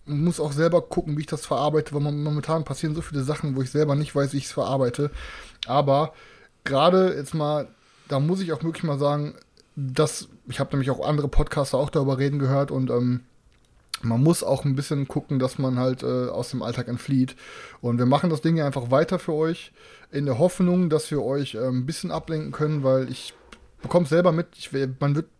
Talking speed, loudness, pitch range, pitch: 215 wpm, -24 LUFS, 135-160 Hz, 145 Hz